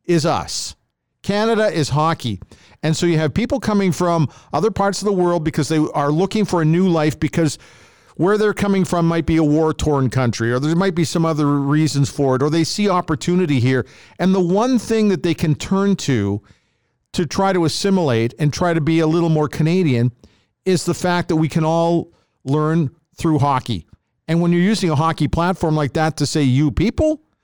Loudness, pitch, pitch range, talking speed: -18 LUFS, 165 Hz, 145-180 Hz, 205 wpm